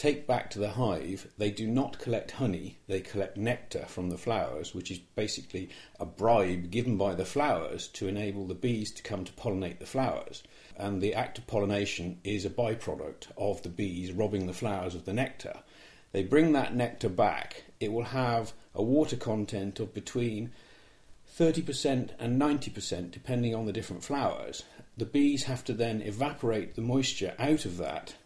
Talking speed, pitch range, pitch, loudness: 180 wpm, 100-125 Hz, 110 Hz, -32 LUFS